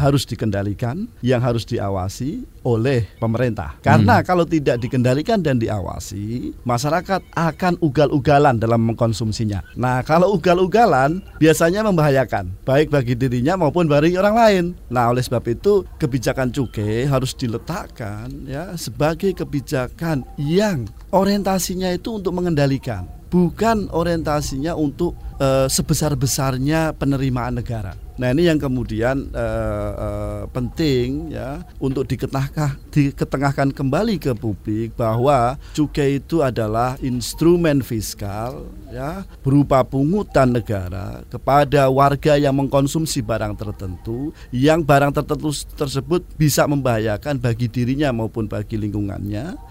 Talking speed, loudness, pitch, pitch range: 115 wpm, -19 LUFS, 135 Hz, 115-155 Hz